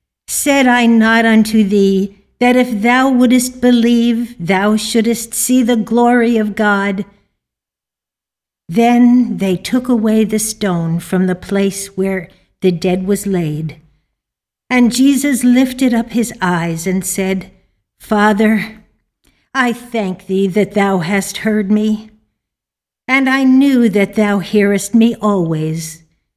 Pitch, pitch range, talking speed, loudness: 215 Hz, 190-240 Hz, 125 wpm, -13 LUFS